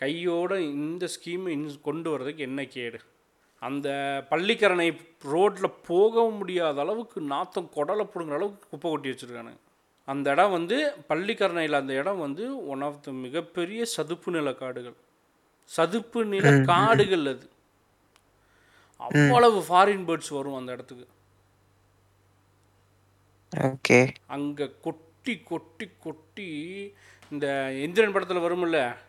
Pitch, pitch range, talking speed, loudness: 150 Hz, 130-180 Hz, 110 wpm, -26 LUFS